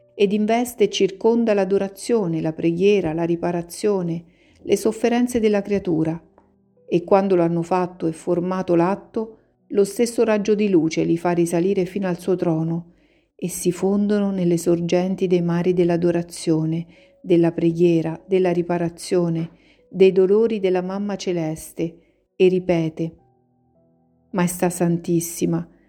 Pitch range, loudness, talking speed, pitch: 170-195 Hz, -21 LUFS, 125 wpm, 175 Hz